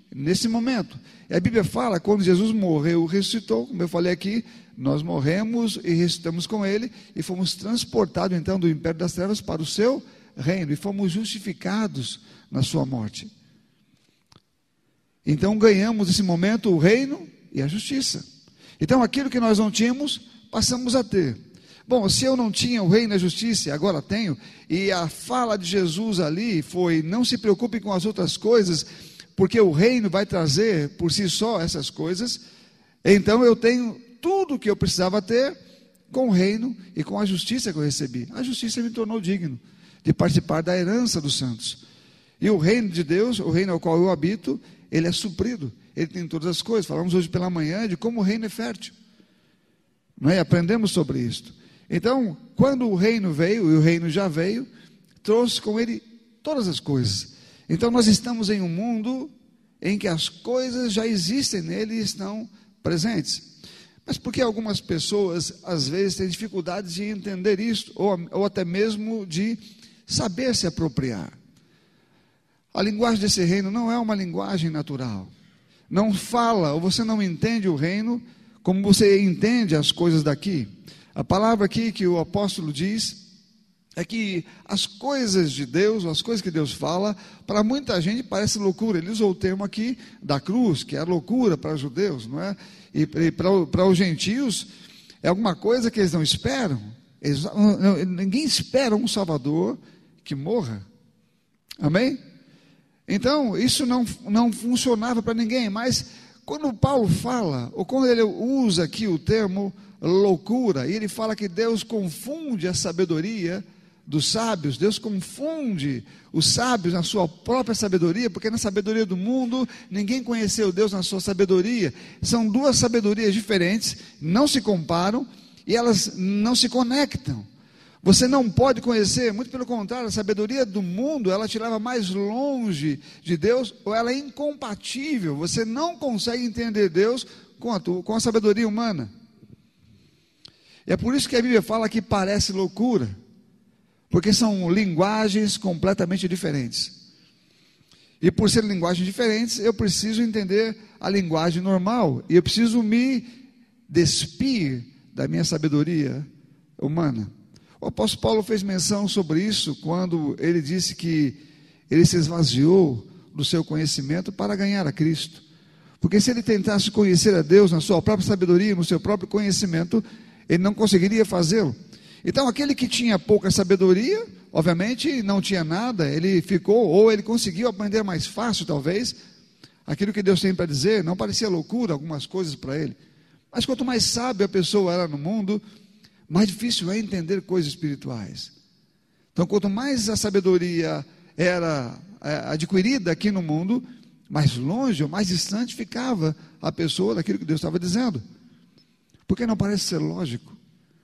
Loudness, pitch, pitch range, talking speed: -23 LUFS, 200 Hz, 175-225 Hz, 160 wpm